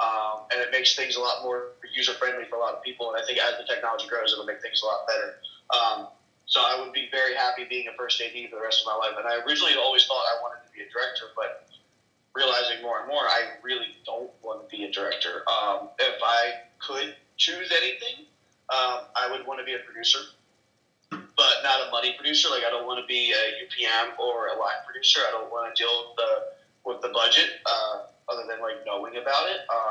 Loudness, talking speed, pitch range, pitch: -25 LUFS, 235 wpm, 115-130 Hz, 120 Hz